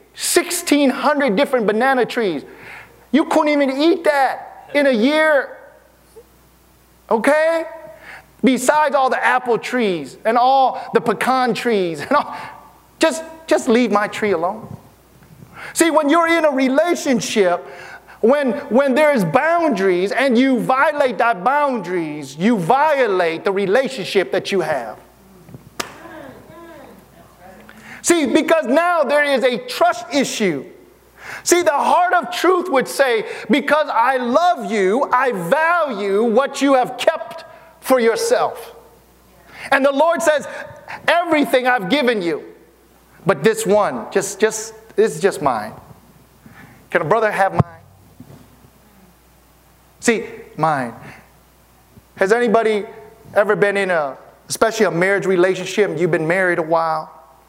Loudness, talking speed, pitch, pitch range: -17 LUFS, 125 wpm, 255 Hz, 200-310 Hz